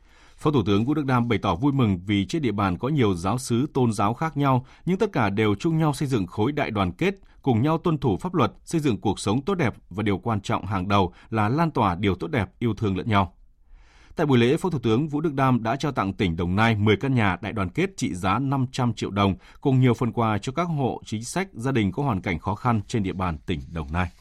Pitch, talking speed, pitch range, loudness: 115 Hz, 275 wpm, 100-135 Hz, -24 LUFS